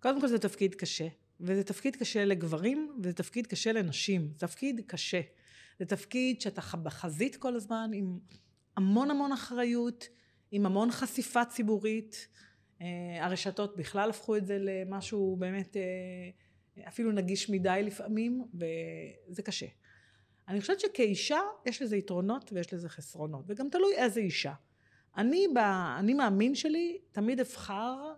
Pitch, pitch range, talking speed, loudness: 200 Hz, 180-240 Hz, 135 wpm, -33 LUFS